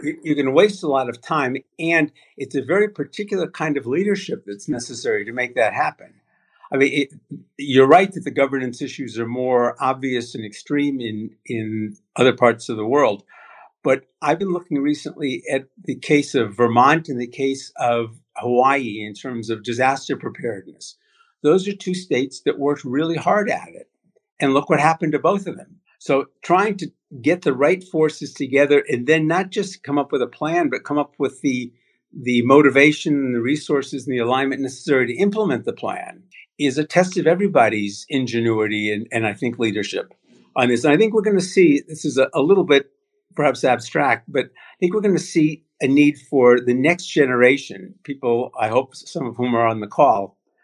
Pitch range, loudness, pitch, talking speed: 125-165 Hz, -19 LUFS, 140 Hz, 200 wpm